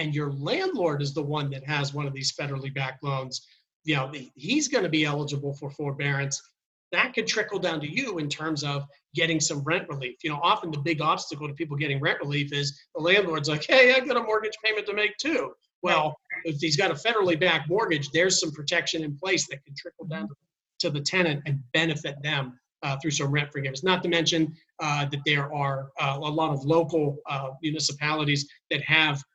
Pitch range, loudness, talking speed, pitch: 145-170 Hz, -26 LUFS, 215 wpm, 155 Hz